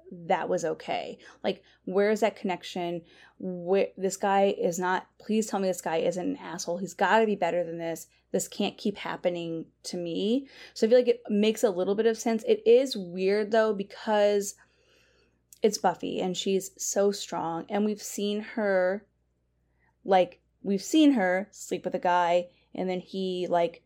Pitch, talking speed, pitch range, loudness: 190 Hz, 180 wpm, 175-215 Hz, -28 LUFS